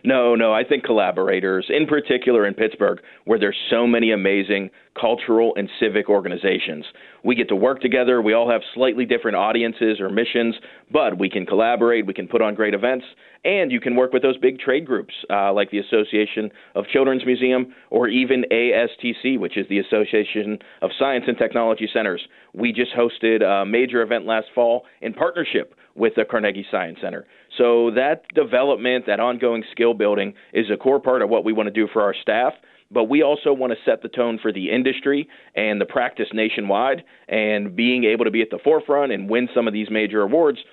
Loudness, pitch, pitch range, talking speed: -20 LUFS, 115 Hz, 105-125 Hz, 195 wpm